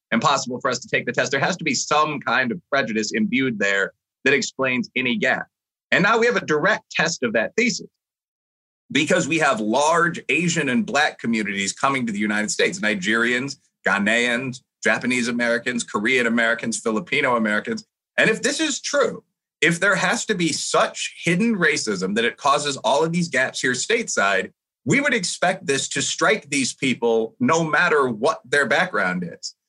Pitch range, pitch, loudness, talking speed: 120-195 Hz, 140 Hz, -20 LUFS, 180 wpm